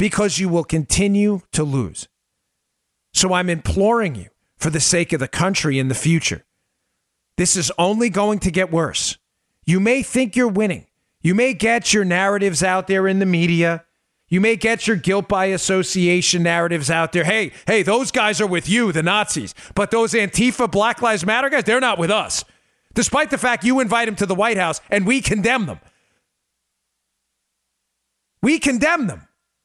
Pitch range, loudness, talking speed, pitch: 170-225 Hz, -18 LUFS, 180 wpm, 195 Hz